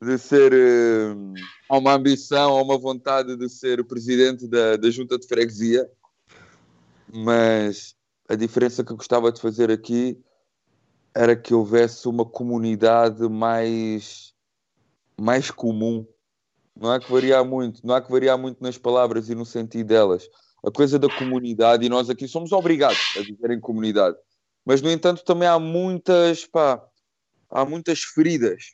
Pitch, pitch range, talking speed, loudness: 120 Hz, 115-135 Hz, 155 wpm, -21 LUFS